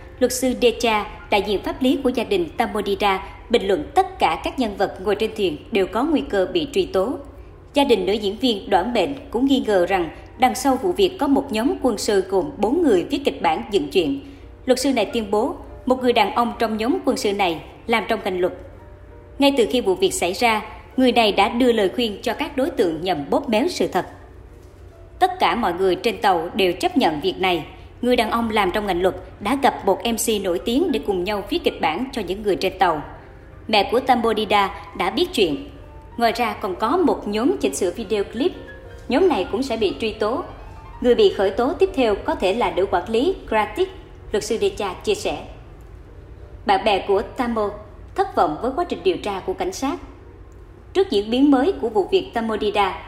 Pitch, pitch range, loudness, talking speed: 240 Hz, 210-320 Hz, -21 LUFS, 220 wpm